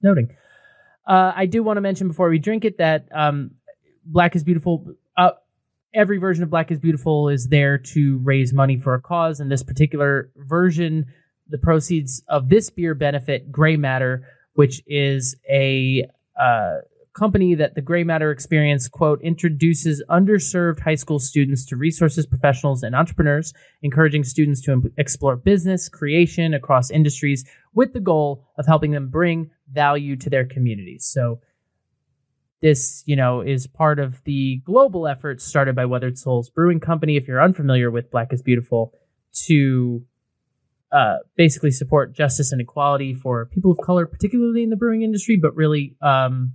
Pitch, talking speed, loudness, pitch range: 150 Hz, 160 wpm, -19 LUFS, 135-170 Hz